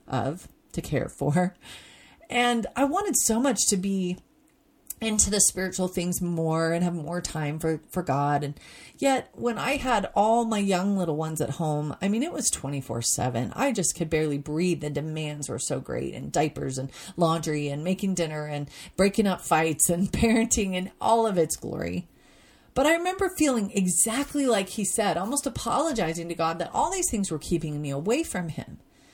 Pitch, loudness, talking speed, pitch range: 185 Hz, -26 LUFS, 185 wpm, 155-230 Hz